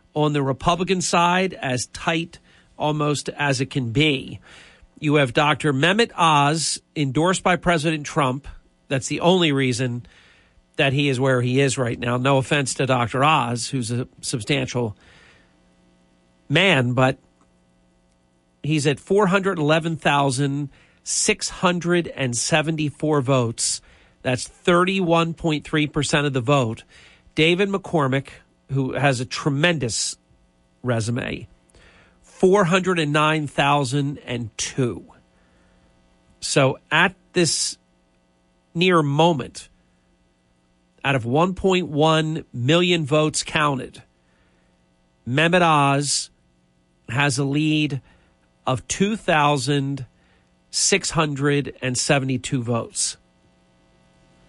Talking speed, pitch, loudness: 85 wpm, 140 Hz, -21 LUFS